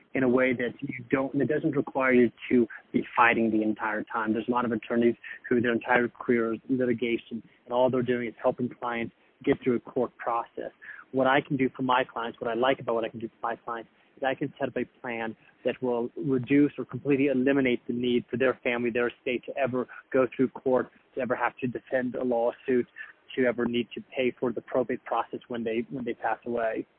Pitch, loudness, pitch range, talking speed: 125 Hz, -28 LUFS, 120-130 Hz, 235 wpm